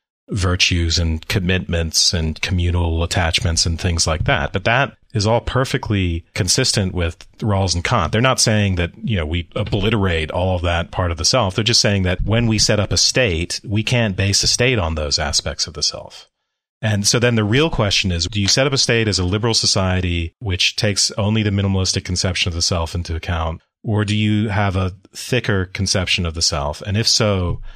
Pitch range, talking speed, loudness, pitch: 85-110 Hz, 210 wpm, -17 LUFS, 95 Hz